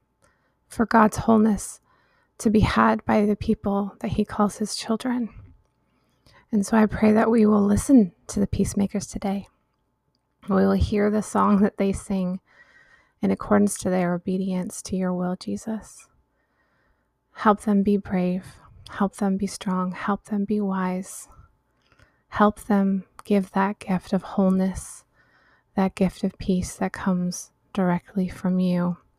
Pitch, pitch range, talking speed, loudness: 195 Hz, 185-210 Hz, 145 wpm, -23 LUFS